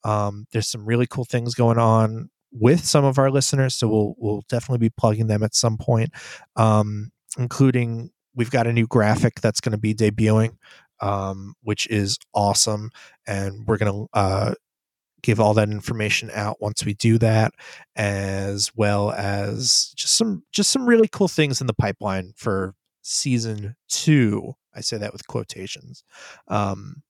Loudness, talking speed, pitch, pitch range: -21 LUFS, 165 wpm, 110 Hz, 105-125 Hz